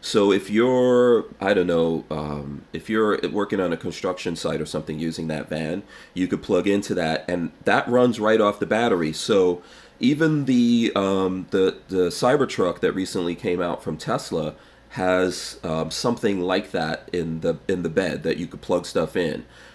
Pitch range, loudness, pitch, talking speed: 80-110 Hz, -23 LUFS, 90 Hz, 180 wpm